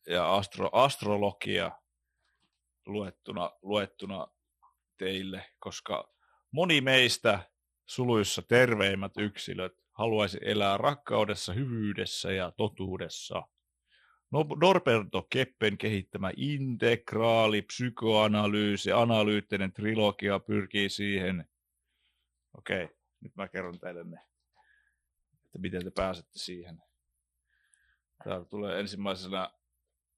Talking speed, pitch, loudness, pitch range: 85 wpm, 100 Hz, -30 LUFS, 90-110 Hz